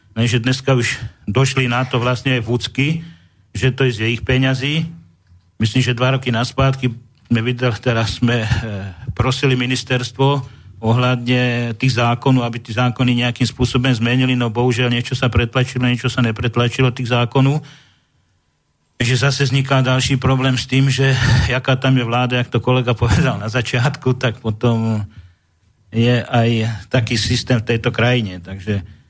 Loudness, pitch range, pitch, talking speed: -17 LUFS, 115-130 Hz, 125 Hz, 150 wpm